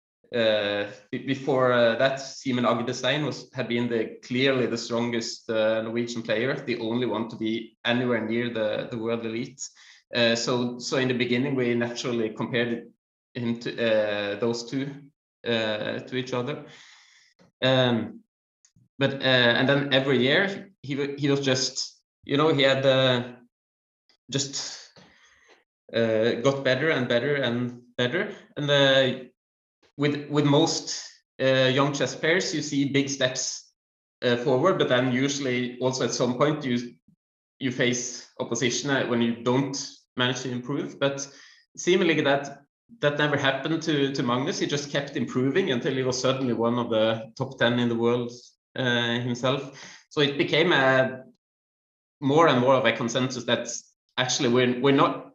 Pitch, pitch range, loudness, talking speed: 125 Hz, 120-140 Hz, -25 LUFS, 160 wpm